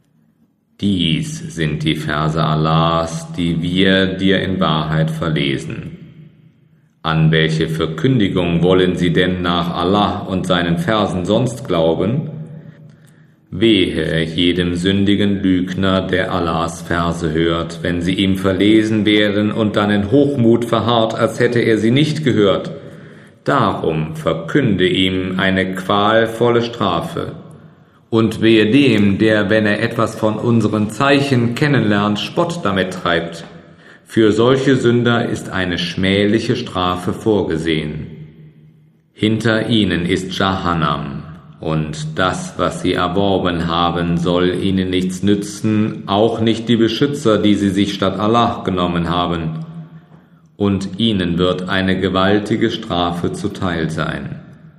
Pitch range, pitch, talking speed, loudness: 85-115 Hz, 100 Hz, 120 wpm, -16 LUFS